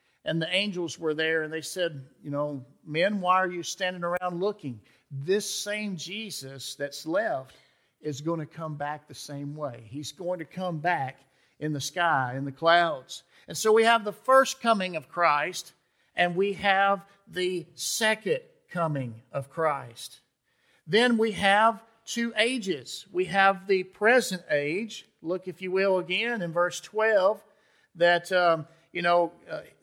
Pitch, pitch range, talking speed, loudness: 175 Hz, 150-200 Hz, 165 wpm, -27 LUFS